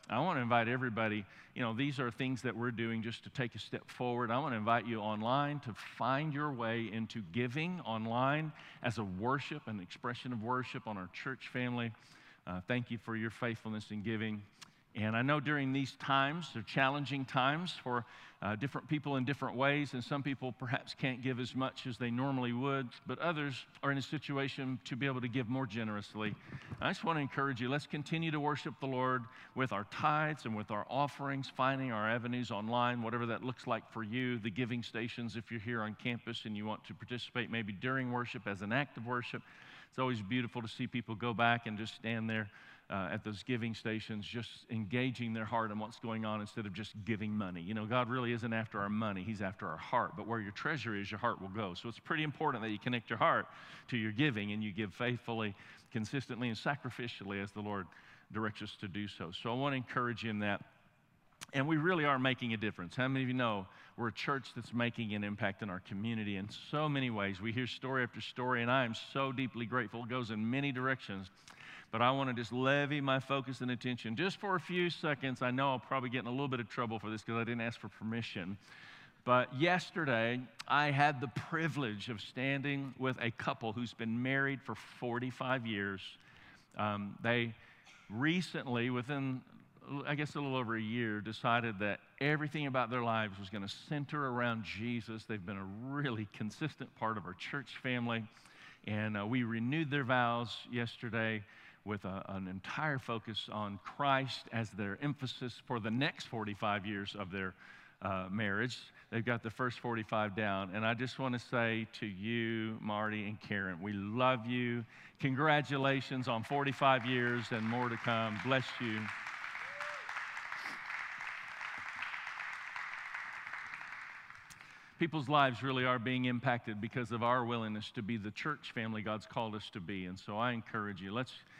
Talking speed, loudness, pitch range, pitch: 200 wpm, -37 LUFS, 110-130 Hz, 120 Hz